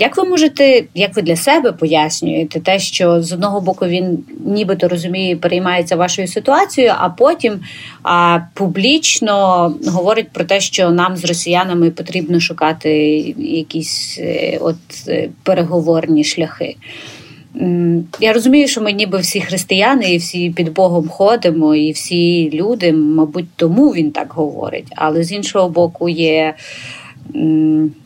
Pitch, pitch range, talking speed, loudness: 175 Hz, 165-200 Hz, 135 wpm, -14 LUFS